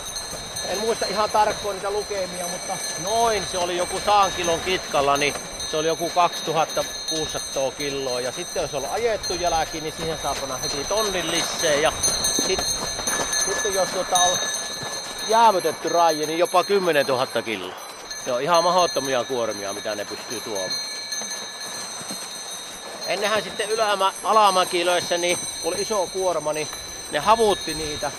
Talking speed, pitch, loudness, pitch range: 145 wpm, 175 Hz, -22 LUFS, 155-195 Hz